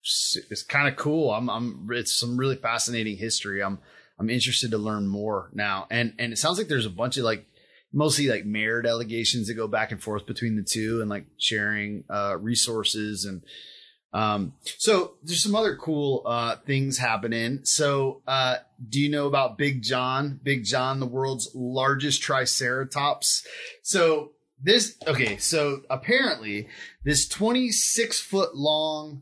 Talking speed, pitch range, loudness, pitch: 160 wpm, 110-145 Hz, -25 LUFS, 125 Hz